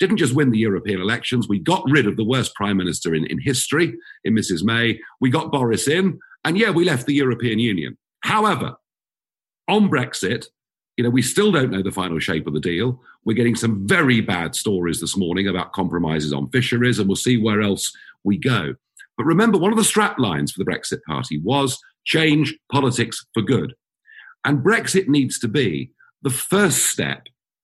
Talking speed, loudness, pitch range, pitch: 195 wpm, -20 LUFS, 100-150 Hz, 125 Hz